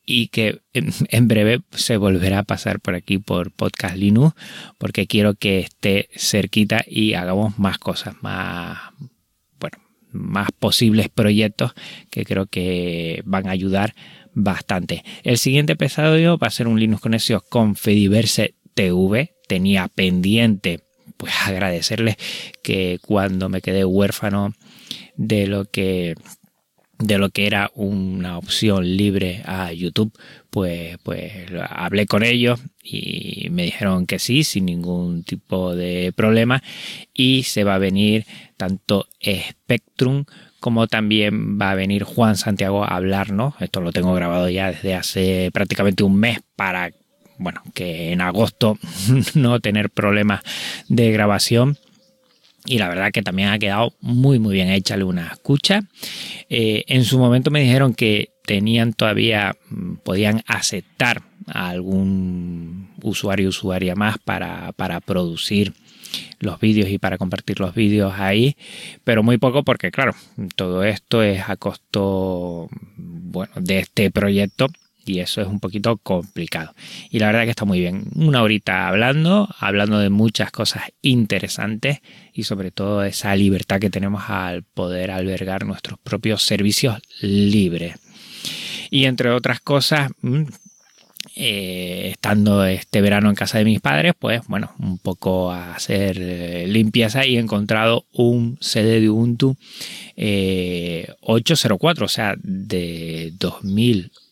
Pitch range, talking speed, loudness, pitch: 95-115 Hz, 140 wpm, -19 LUFS, 105 Hz